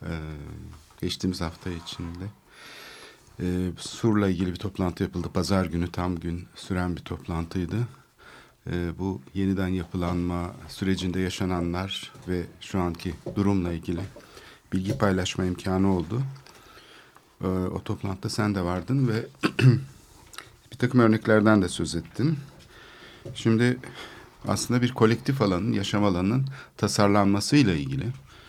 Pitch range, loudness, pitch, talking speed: 90-110 Hz, -26 LUFS, 95 Hz, 115 wpm